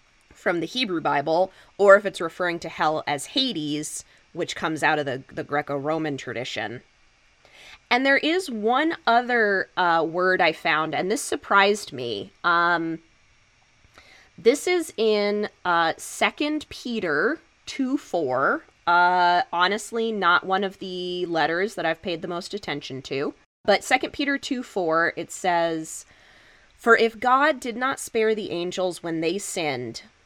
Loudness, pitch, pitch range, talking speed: -23 LUFS, 180 Hz, 160-230 Hz, 145 wpm